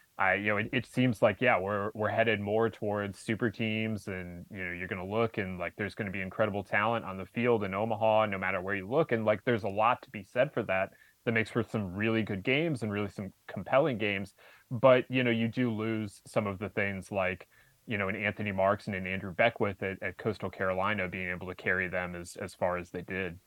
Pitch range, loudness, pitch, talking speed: 95-110 Hz, -31 LUFS, 105 Hz, 250 wpm